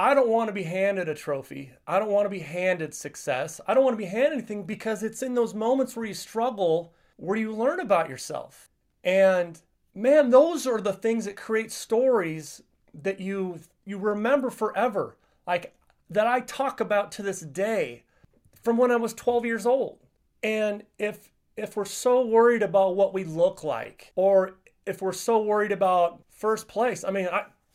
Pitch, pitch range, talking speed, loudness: 210 Hz, 190-235 Hz, 185 wpm, -26 LUFS